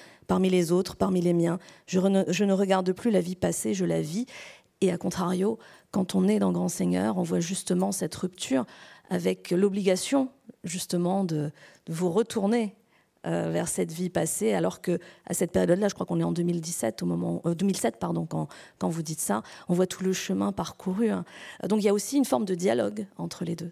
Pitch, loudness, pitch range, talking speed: 185 Hz, -27 LUFS, 170-195 Hz, 210 wpm